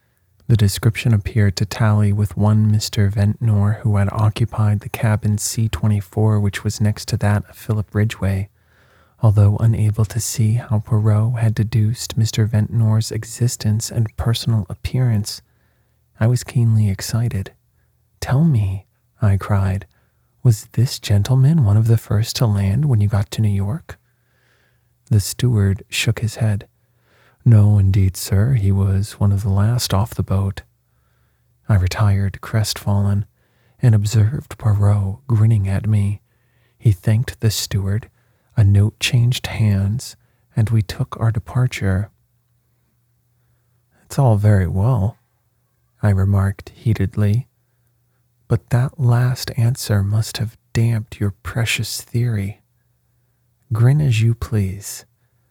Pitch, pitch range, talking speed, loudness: 110 Hz, 100-120 Hz, 130 wpm, -18 LUFS